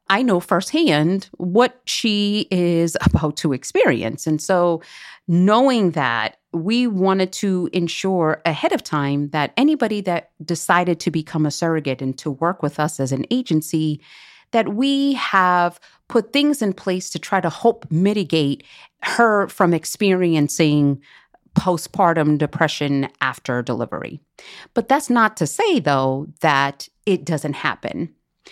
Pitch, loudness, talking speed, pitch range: 170 Hz, -19 LUFS, 135 wpm, 150-200 Hz